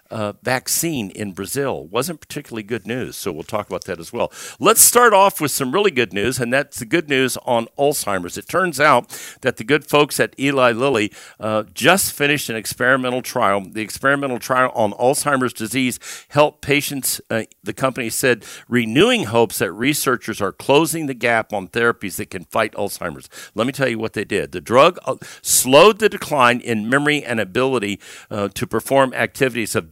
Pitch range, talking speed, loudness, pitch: 110-140 Hz, 190 wpm, -18 LUFS, 125 Hz